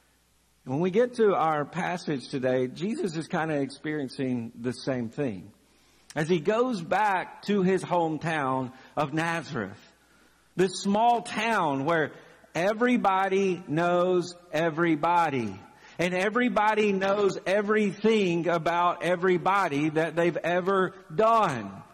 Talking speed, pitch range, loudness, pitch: 110 wpm, 150-195 Hz, -26 LUFS, 175 Hz